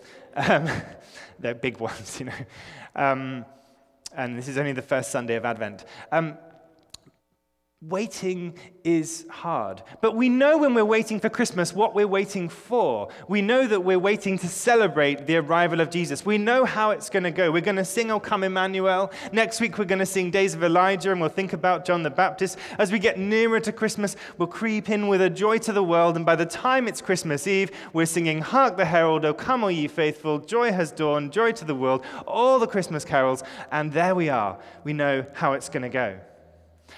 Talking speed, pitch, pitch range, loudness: 205 wpm, 180 Hz, 150-205 Hz, -23 LUFS